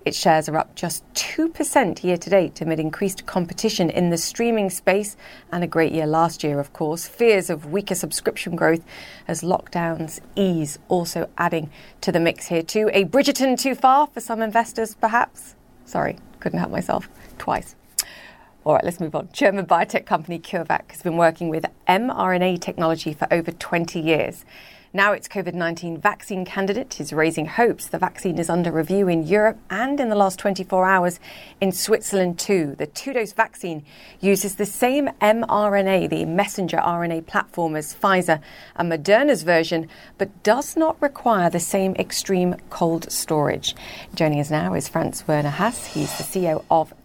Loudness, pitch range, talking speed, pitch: -22 LUFS, 165-210 Hz, 170 wpm, 180 Hz